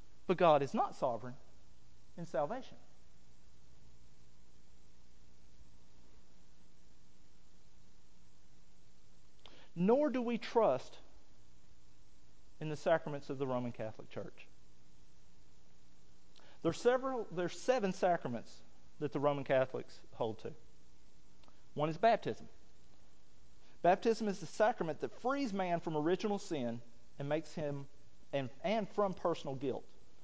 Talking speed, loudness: 105 wpm, -36 LUFS